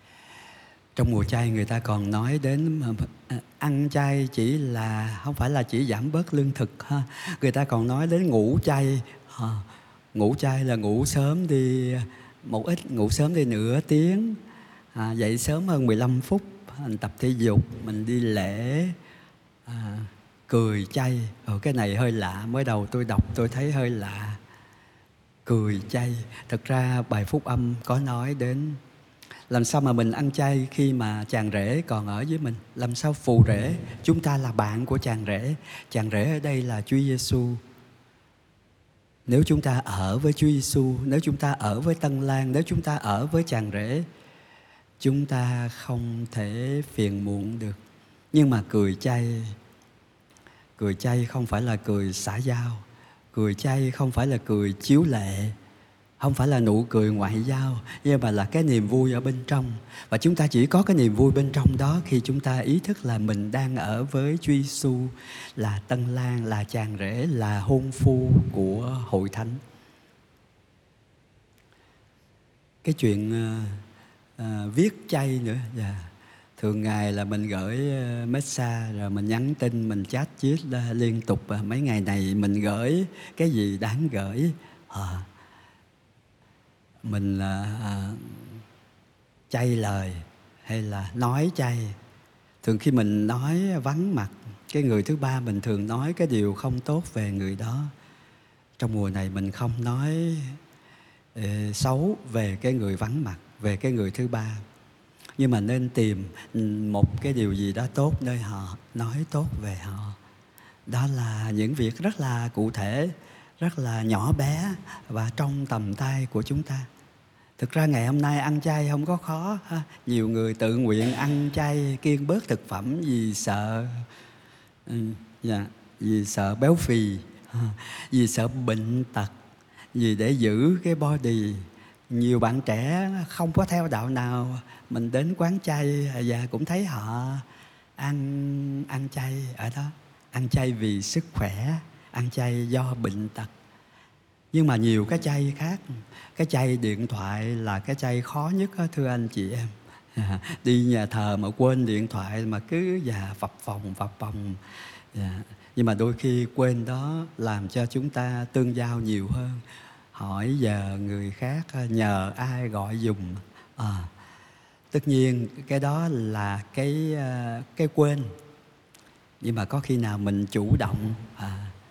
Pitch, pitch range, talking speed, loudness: 120 Hz, 110-140 Hz, 165 wpm, -26 LUFS